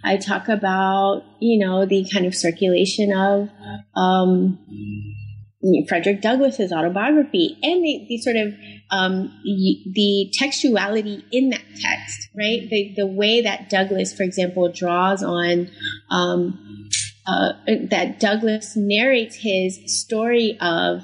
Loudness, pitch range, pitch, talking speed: -20 LUFS, 175-215 Hz, 195 Hz, 125 wpm